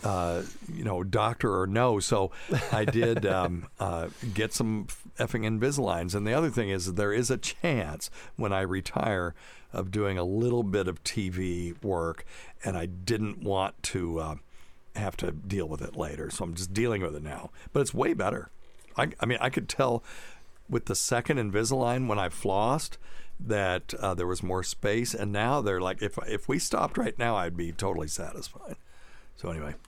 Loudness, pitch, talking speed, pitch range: -30 LUFS, 100 Hz, 190 wpm, 90-115 Hz